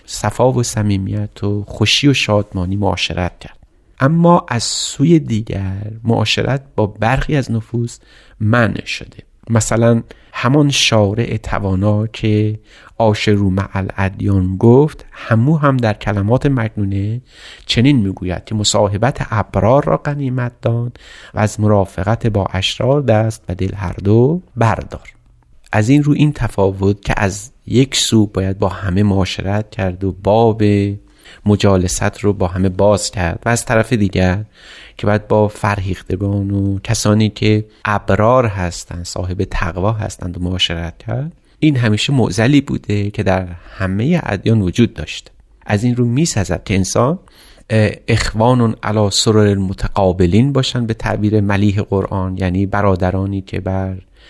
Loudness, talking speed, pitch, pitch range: -16 LUFS, 135 wpm, 105 Hz, 95-115 Hz